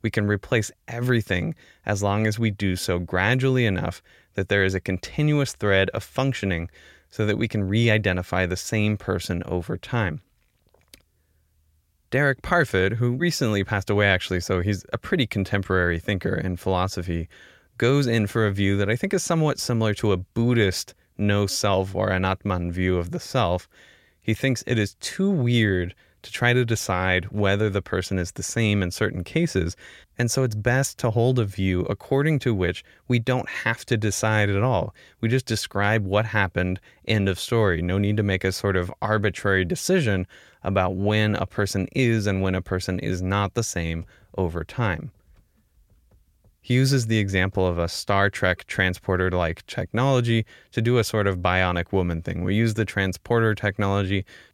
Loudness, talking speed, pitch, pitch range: -24 LUFS, 180 wpm, 100 Hz, 95-115 Hz